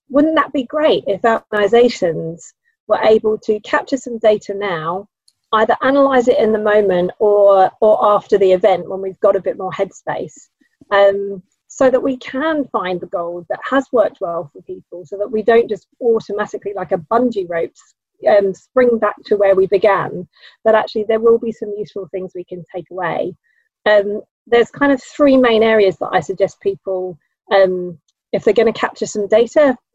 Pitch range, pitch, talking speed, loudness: 195-235 Hz, 210 Hz, 185 wpm, -16 LUFS